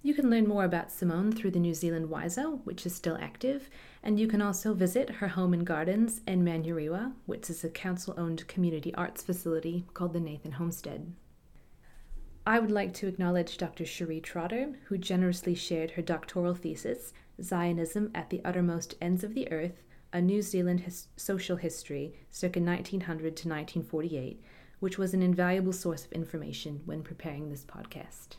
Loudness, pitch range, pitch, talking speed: -32 LUFS, 165-195 Hz, 175 Hz, 170 wpm